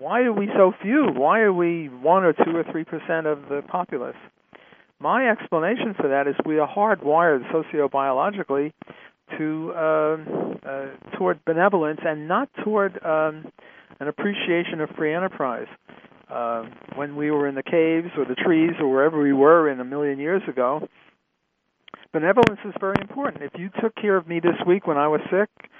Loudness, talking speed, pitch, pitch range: -22 LUFS, 170 wpm, 160 Hz, 145-190 Hz